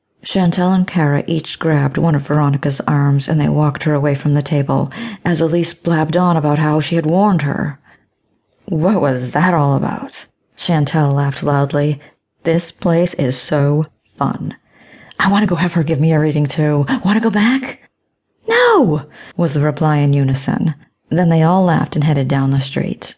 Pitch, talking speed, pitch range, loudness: 155 Hz, 180 wpm, 145-175 Hz, -15 LUFS